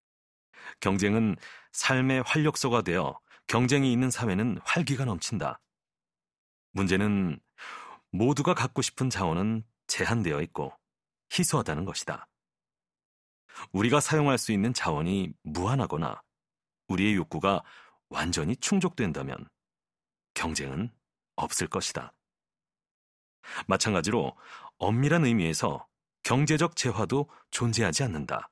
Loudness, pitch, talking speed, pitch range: -28 LUFS, 120 Hz, 245 characters per minute, 95-140 Hz